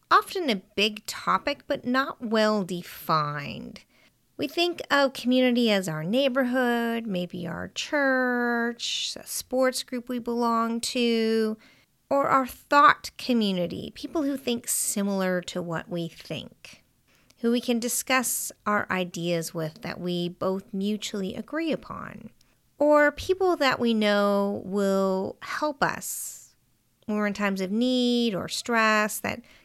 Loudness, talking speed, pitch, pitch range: -26 LUFS, 135 wpm, 230 Hz, 195-260 Hz